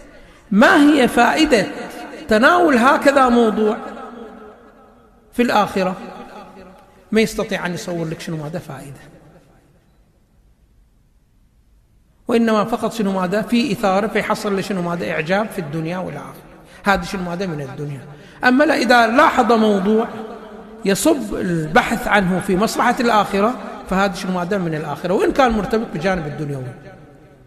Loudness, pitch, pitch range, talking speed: -17 LUFS, 205 Hz, 180-235 Hz, 120 wpm